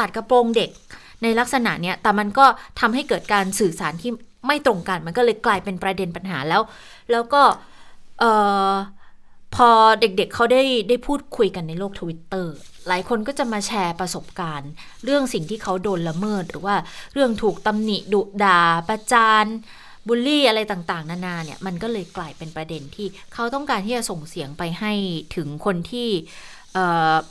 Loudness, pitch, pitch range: -20 LUFS, 200 Hz, 180-235 Hz